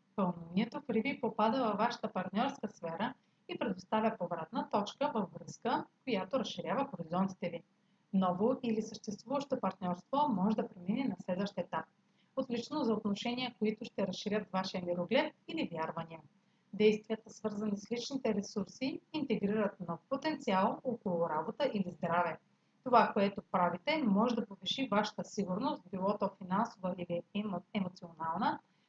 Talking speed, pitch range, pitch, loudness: 130 wpm, 185-235 Hz, 210 Hz, -36 LUFS